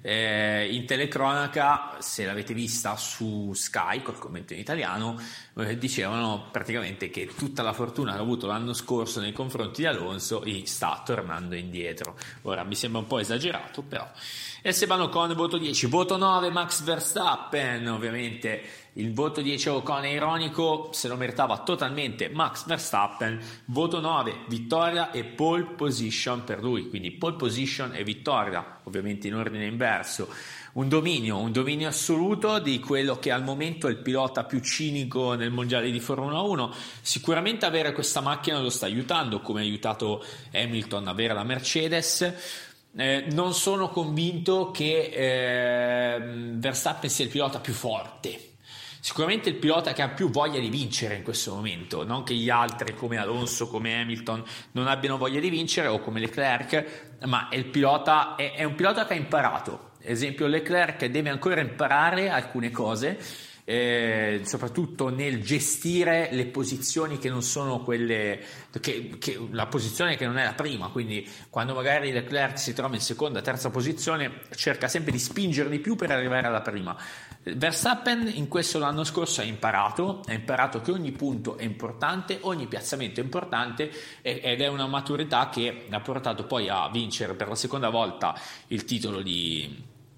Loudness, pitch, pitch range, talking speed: -27 LUFS, 130 Hz, 115-150 Hz, 160 wpm